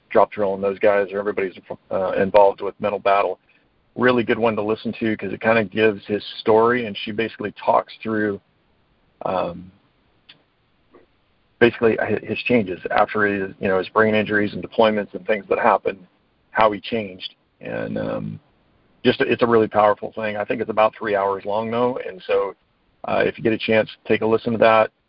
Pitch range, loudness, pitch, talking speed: 105-115 Hz, -20 LUFS, 110 Hz, 190 wpm